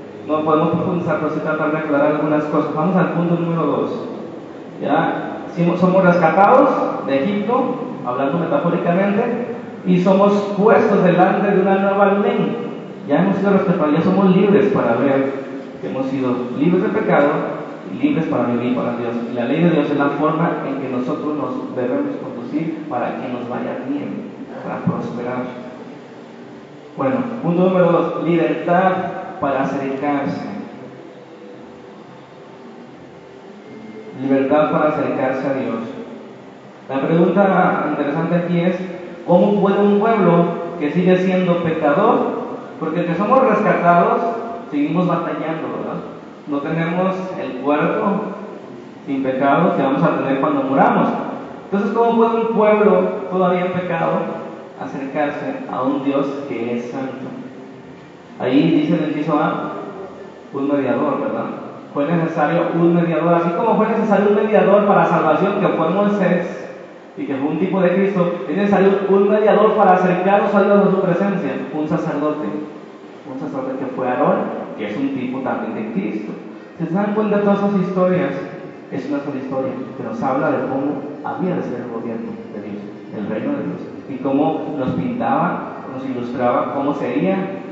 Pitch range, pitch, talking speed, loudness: 150-200 Hz, 175 Hz, 150 wpm, -18 LUFS